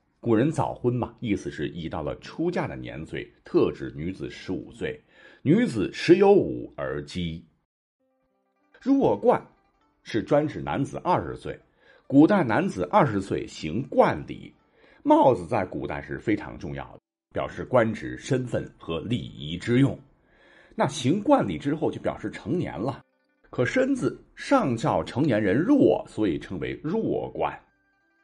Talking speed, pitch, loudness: 210 characters per minute, 130 Hz, -25 LUFS